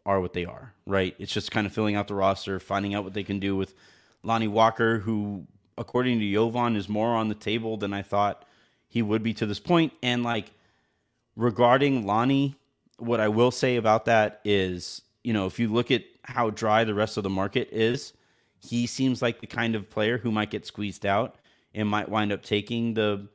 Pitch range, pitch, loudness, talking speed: 100-115 Hz, 110 Hz, -26 LUFS, 215 wpm